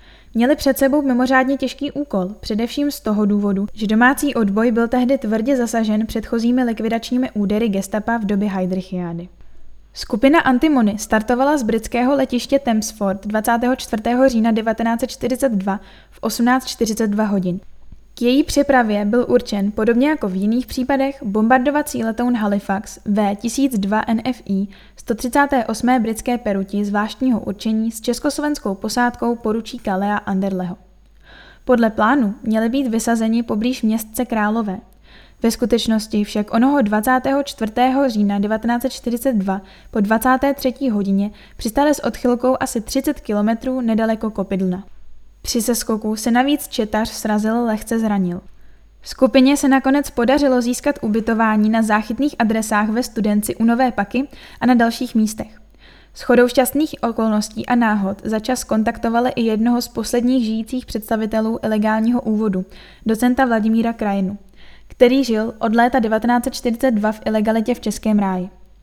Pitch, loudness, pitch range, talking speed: 230 Hz, -18 LUFS, 215-255 Hz, 125 wpm